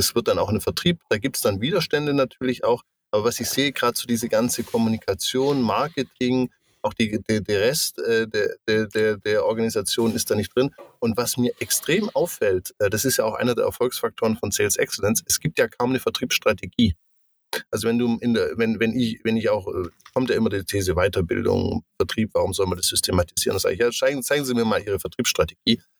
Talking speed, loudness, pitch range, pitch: 215 wpm, -23 LUFS, 115-135 Hz, 120 Hz